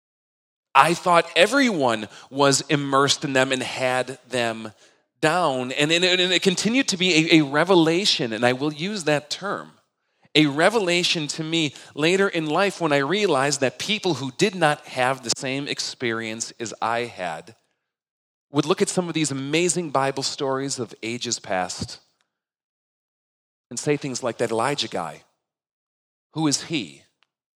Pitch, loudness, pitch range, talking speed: 145 Hz, -22 LUFS, 130-170 Hz, 150 wpm